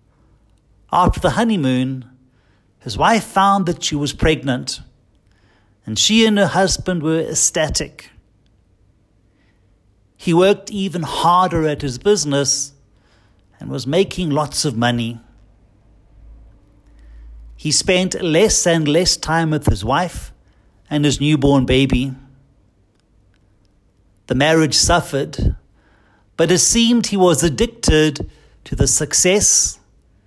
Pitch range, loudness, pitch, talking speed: 105-165 Hz, -16 LUFS, 135 Hz, 110 wpm